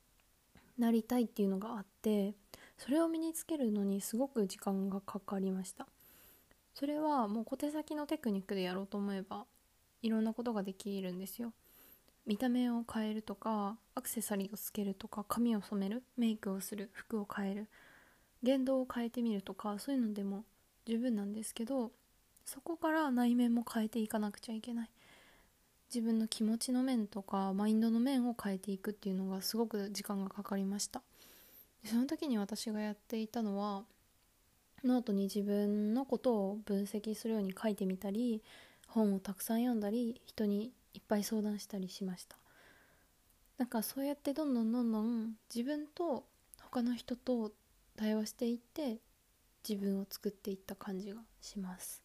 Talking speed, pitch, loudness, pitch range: 355 characters per minute, 220 Hz, -38 LUFS, 200-240 Hz